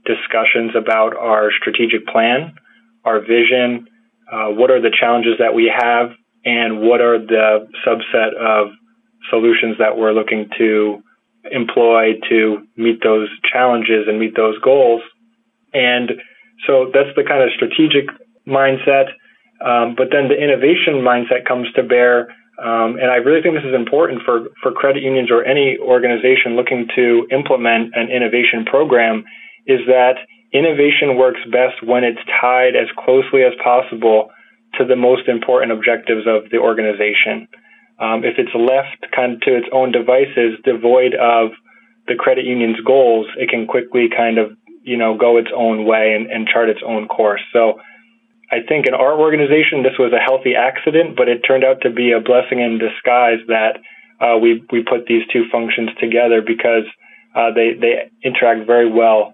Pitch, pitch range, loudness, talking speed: 120 Hz, 115-130 Hz, -14 LUFS, 165 wpm